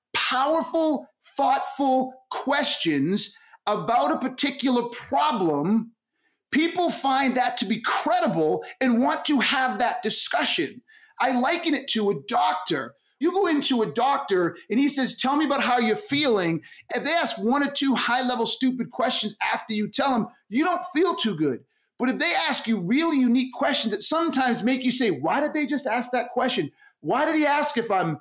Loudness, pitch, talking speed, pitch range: -23 LUFS, 260 Hz, 180 wpm, 230-295 Hz